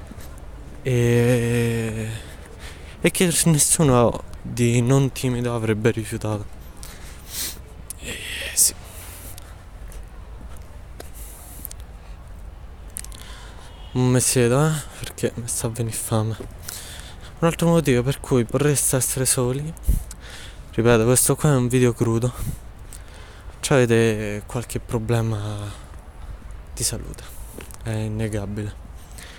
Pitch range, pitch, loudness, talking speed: 85-120 Hz, 105 Hz, -21 LUFS, 90 wpm